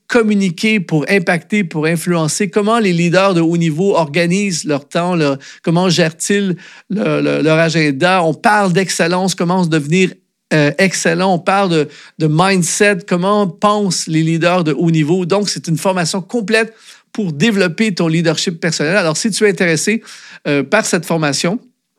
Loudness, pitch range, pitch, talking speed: -14 LUFS, 165-200 Hz, 180 Hz, 160 wpm